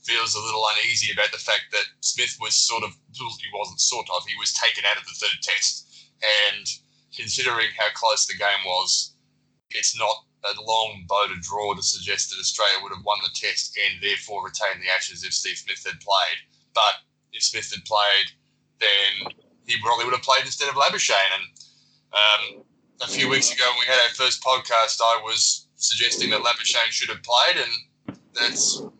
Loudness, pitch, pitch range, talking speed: -21 LUFS, 110 Hz, 100-115 Hz, 190 wpm